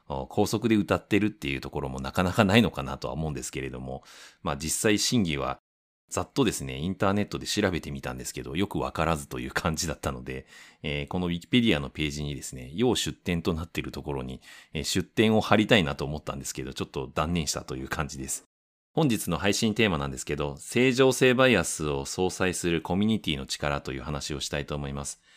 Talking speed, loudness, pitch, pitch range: 455 characters per minute, -27 LUFS, 75 Hz, 70-95 Hz